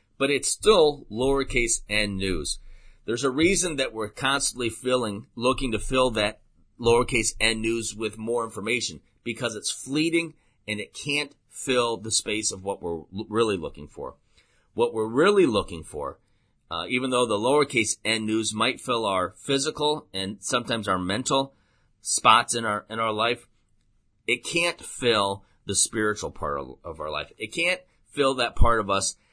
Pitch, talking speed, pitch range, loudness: 115 Hz, 170 wpm, 105-130 Hz, -25 LUFS